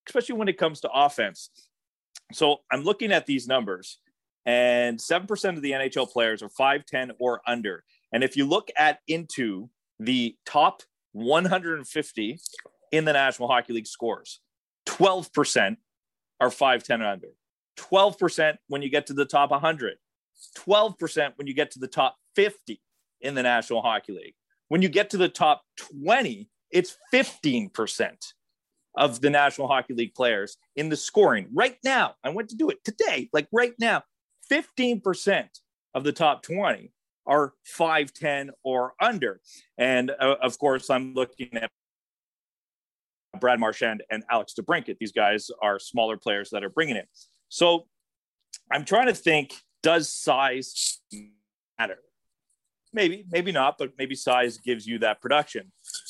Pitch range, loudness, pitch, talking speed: 130-195 Hz, -25 LUFS, 150 Hz, 155 wpm